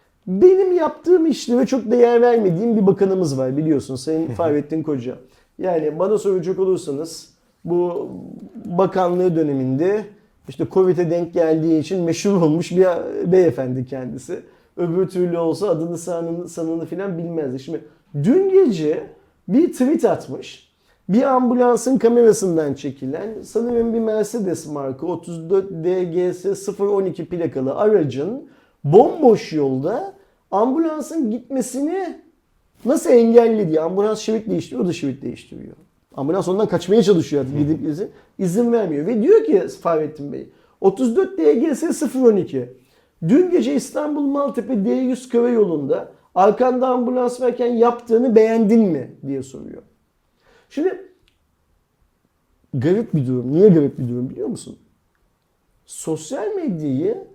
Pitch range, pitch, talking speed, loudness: 160-245 Hz, 195 Hz, 120 wpm, -18 LUFS